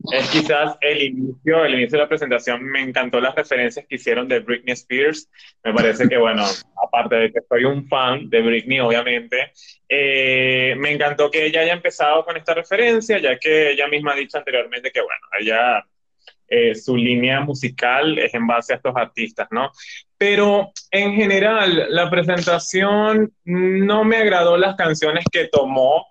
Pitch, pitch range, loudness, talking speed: 155 Hz, 130-195 Hz, -18 LUFS, 170 wpm